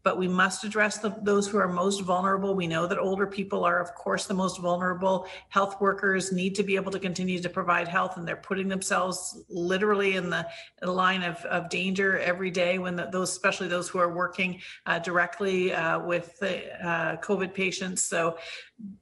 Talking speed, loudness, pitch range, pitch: 195 wpm, -27 LUFS, 175-195 Hz, 185 Hz